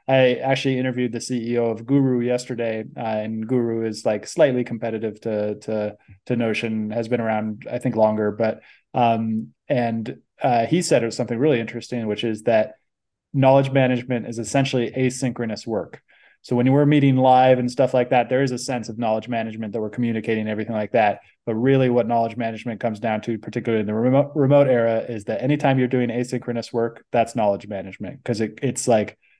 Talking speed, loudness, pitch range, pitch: 195 wpm, -21 LUFS, 110-125 Hz, 120 Hz